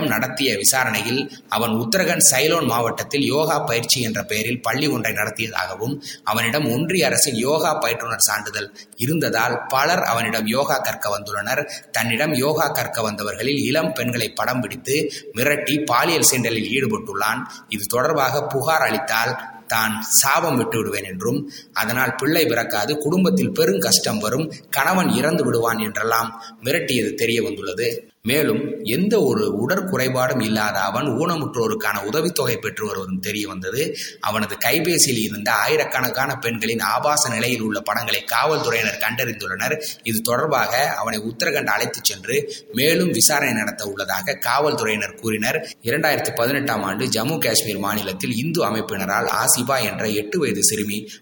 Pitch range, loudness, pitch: 110-145 Hz, -20 LUFS, 120 Hz